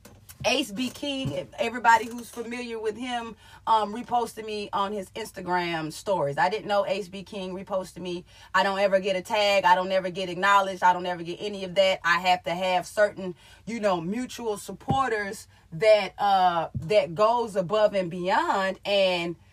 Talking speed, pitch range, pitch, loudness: 180 wpm, 180-215 Hz, 195 Hz, -25 LUFS